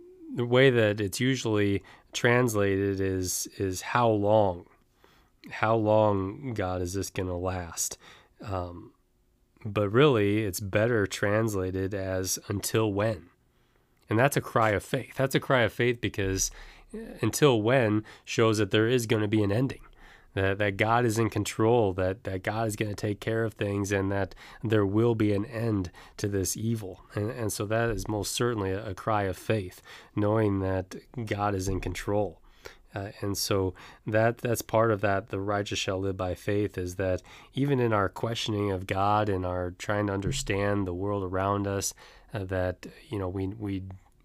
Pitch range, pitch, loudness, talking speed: 95-115 Hz, 105 Hz, -28 LUFS, 175 wpm